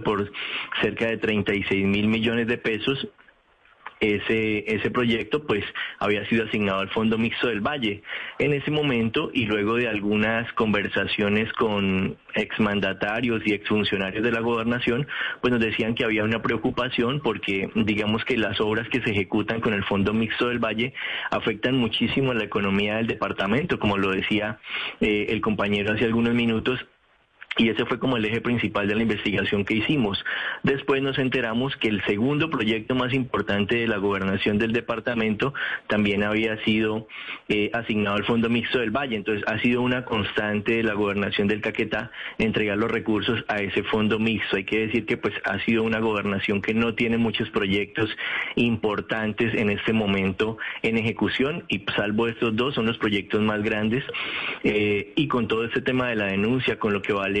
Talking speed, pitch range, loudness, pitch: 175 wpm, 105-120 Hz, -24 LUFS, 110 Hz